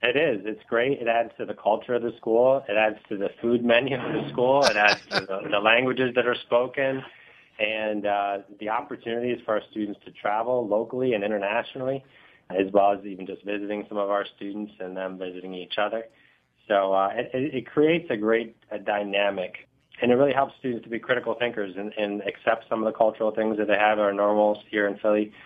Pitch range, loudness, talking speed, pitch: 100-120 Hz, -25 LUFS, 215 wpm, 110 Hz